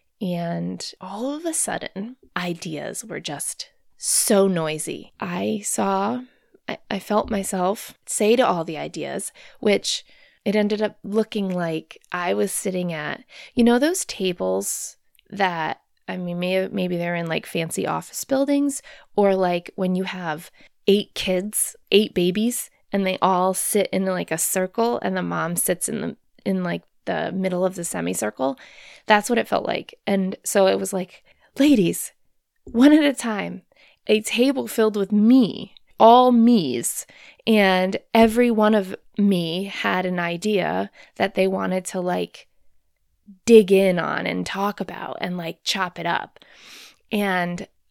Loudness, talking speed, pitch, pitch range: -22 LUFS, 155 wpm, 195 Hz, 180-220 Hz